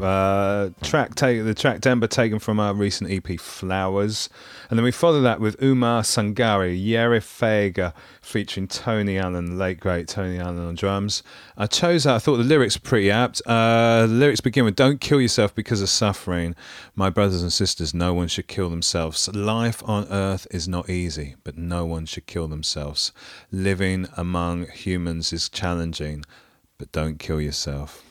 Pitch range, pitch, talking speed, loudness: 85-110 Hz, 95 Hz, 175 wpm, -22 LUFS